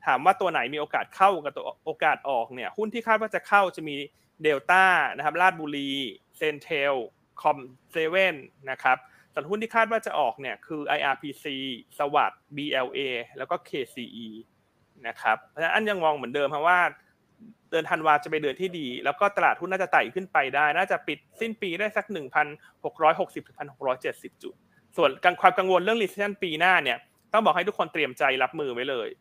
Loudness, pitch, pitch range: -26 LUFS, 160 Hz, 140-195 Hz